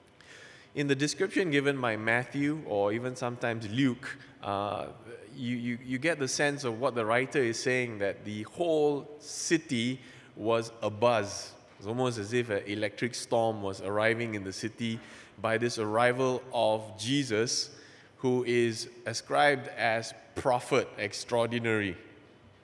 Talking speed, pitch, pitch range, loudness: 140 wpm, 120 Hz, 110-135 Hz, -30 LUFS